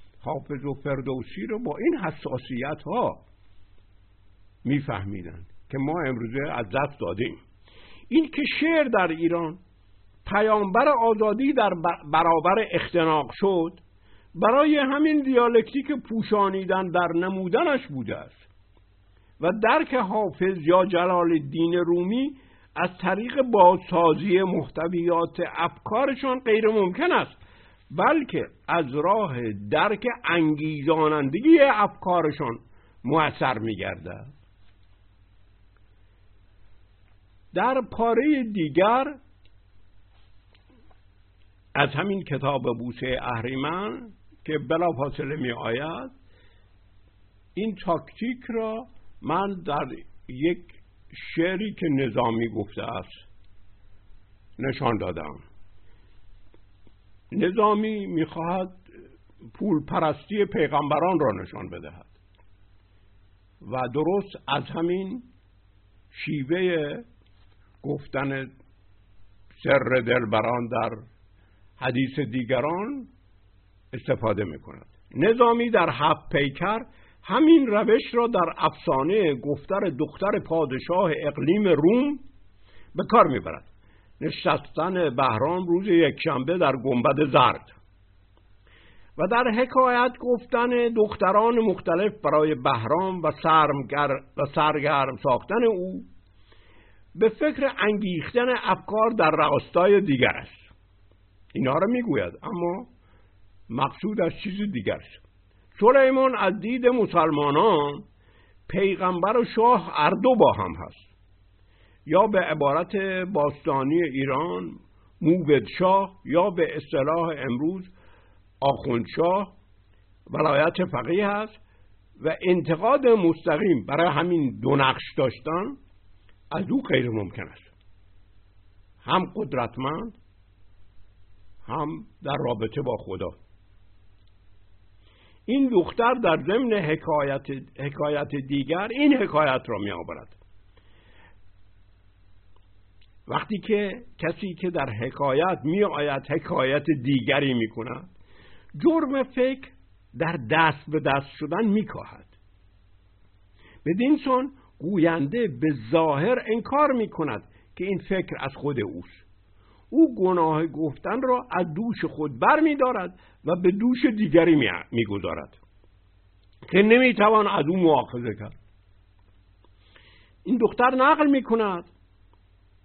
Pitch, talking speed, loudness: 145 Hz, 100 wpm, -24 LUFS